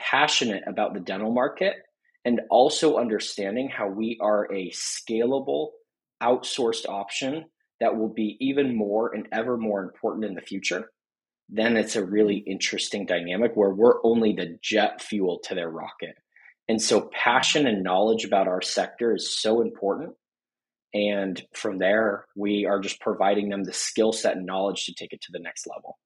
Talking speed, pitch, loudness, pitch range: 170 wpm, 105 Hz, -25 LUFS, 100-115 Hz